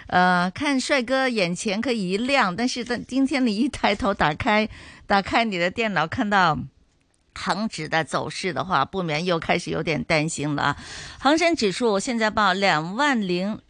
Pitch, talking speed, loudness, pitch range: 200 Hz, 245 characters per minute, -22 LUFS, 180-245 Hz